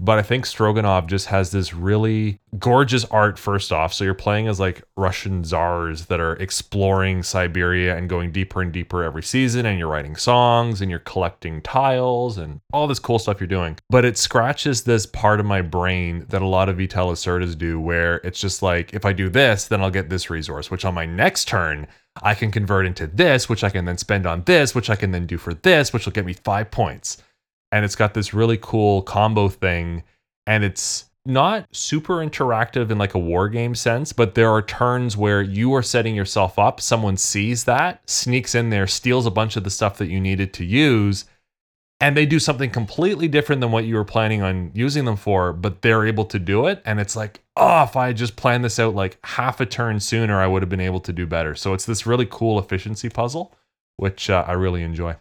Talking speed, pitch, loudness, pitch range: 225 wpm, 100 Hz, -20 LUFS, 95-115 Hz